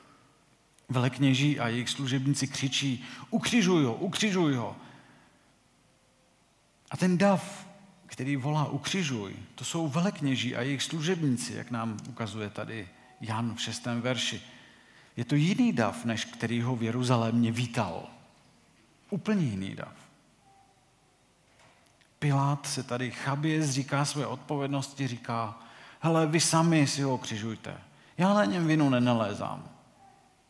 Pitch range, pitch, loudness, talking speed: 120-150 Hz, 135 Hz, -29 LUFS, 120 wpm